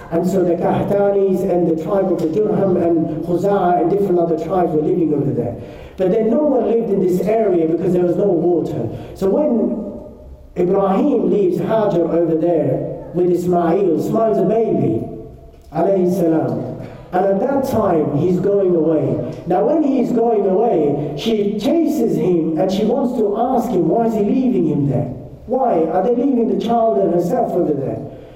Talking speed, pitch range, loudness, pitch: 180 wpm, 165-215 Hz, -17 LUFS, 180 Hz